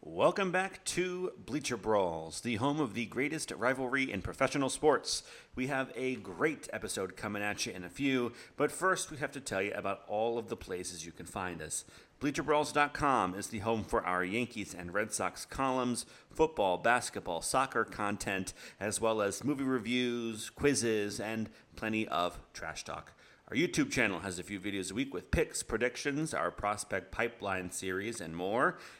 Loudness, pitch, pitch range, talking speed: -34 LUFS, 115 Hz, 95-135 Hz, 175 wpm